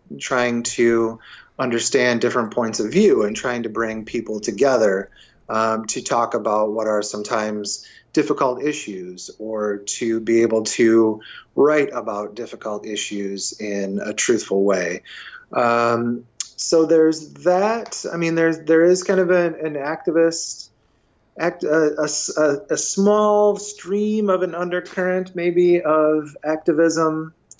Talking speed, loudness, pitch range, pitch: 135 wpm, -20 LUFS, 110-165 Hz, 125 Hz